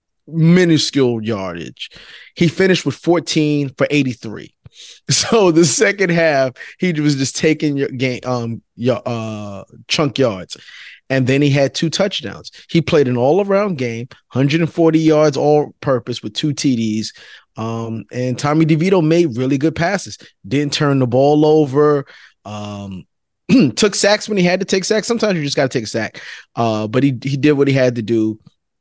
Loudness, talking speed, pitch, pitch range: -16 LUFS, 165 wpm, 140 Hz, 125-165 Hz